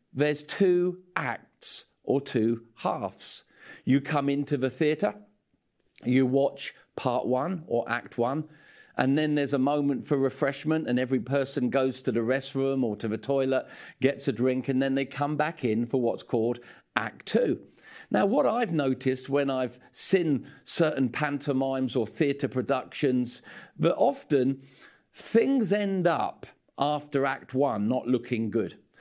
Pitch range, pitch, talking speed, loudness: 130-150 Hz, 135 Hz, 150 wpm, -28 LUFS